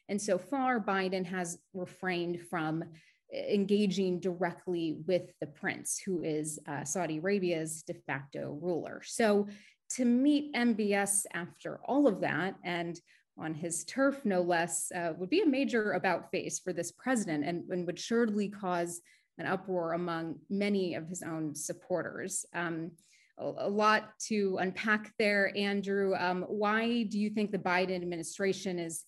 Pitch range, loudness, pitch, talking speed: 170-205 Hz, -33 LUFS, 185 Hz, 155 wpm